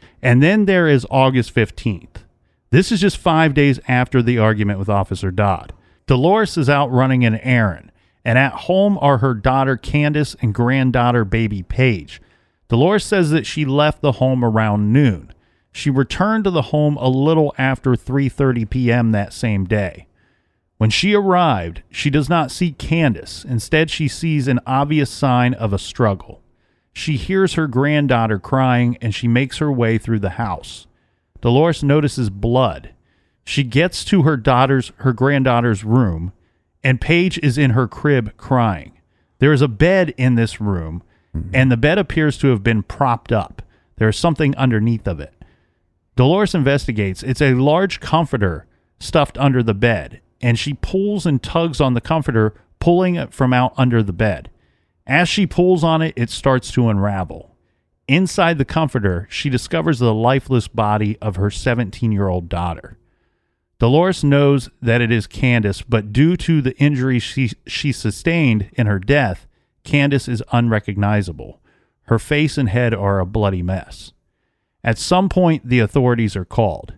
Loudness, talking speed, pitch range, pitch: -17 LUFS, 160 wpm, 105-145 Hz, 125 Hz